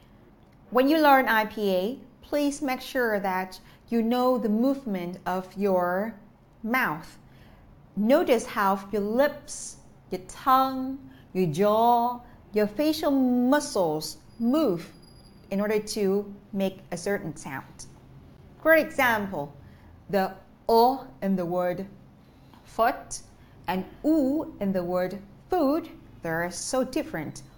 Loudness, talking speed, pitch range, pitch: -26 LUFS, 110 wpm, 185-260 Hz, 210 Hz